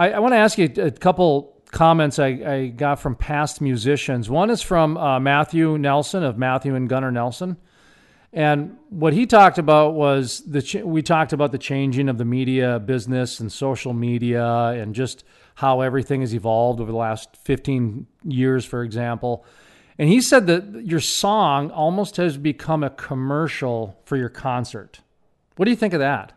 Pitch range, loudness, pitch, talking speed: 125-160 Hz, -20 LUFS, 140 Hz, 175 wpm